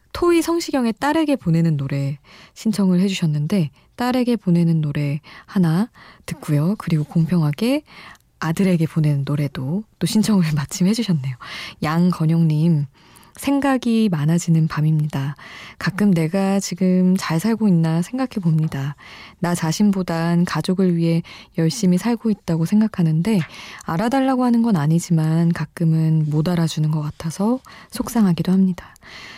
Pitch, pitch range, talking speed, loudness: 175 Hz, 160-210 Hz, 305 characters per minute, -19 LUFS